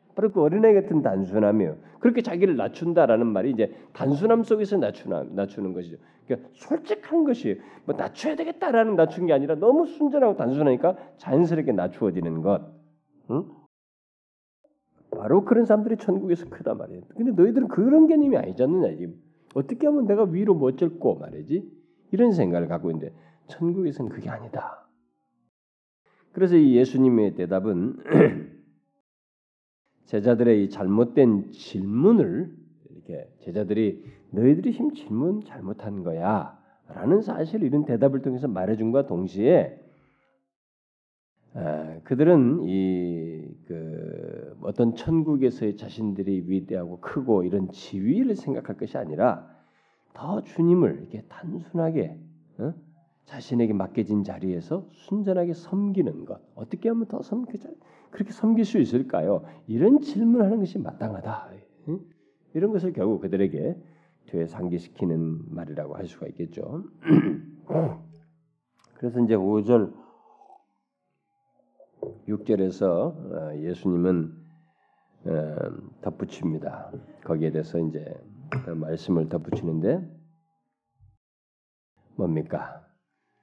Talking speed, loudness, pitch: 275 characters per minute, -24 LUFS, 145 Hz